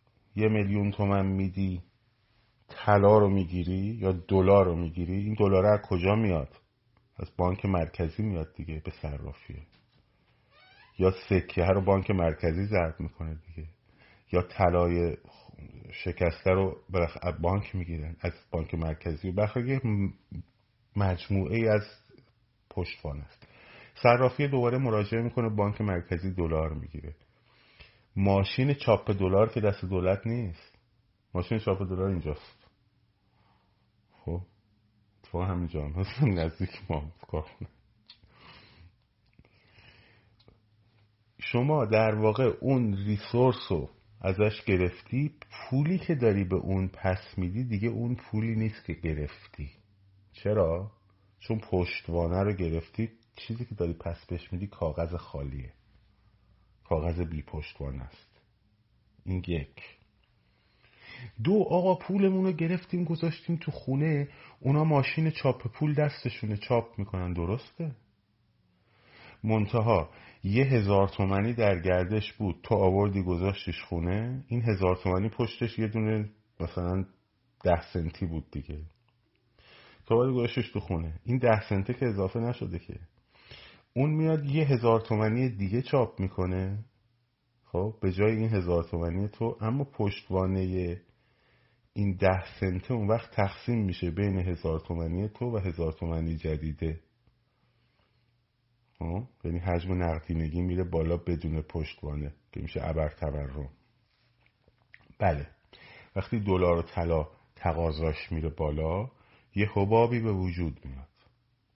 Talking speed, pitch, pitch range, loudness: 120 wpm, 100 Hz, 90-115 Hz, -29 LUFS